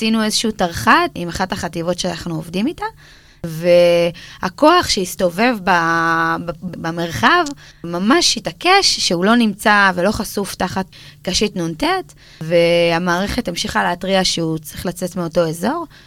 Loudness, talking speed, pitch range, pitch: -16 LUFS, 110 wpm, 170-220 Hz, 180 Hz